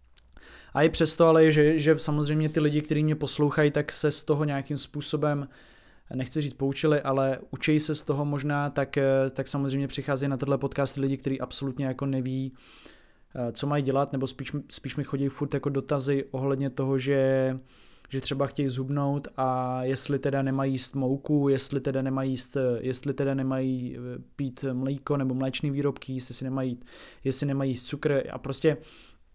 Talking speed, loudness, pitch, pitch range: 170 wpm, -27 LUFS, 140 Hz, 130-145 Hz